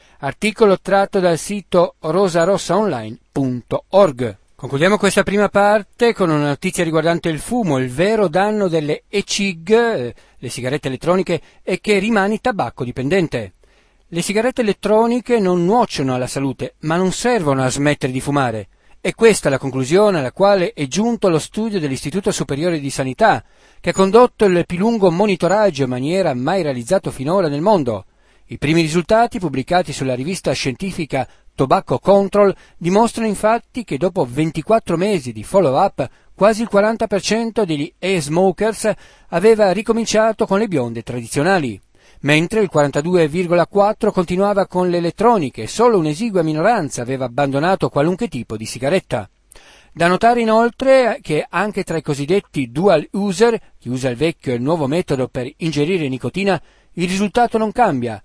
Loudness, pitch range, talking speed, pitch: -17 LUFS, 140-205 Hz, 145 wpm, 180 Hz